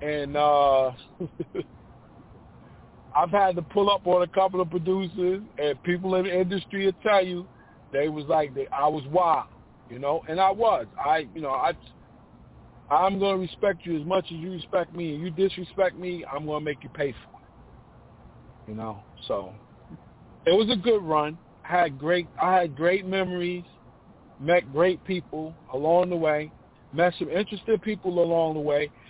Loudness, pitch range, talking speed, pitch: -26 LUFS, 150-185 Hz, 175 wpm, 175 Hz